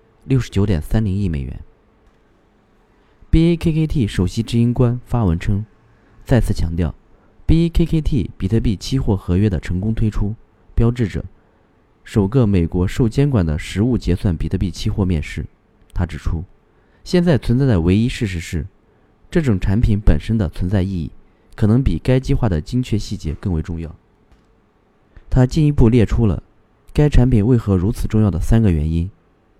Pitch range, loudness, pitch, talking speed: 90-115 Hz, -18 LUFS, 110 Hz, 255 characters per minute